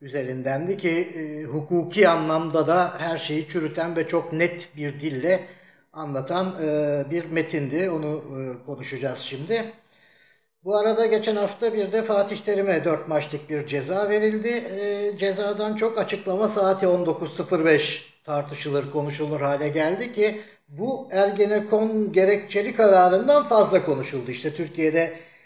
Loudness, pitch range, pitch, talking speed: -23 LUFS, 155-205 Hz, 170 Hz, 120 wpm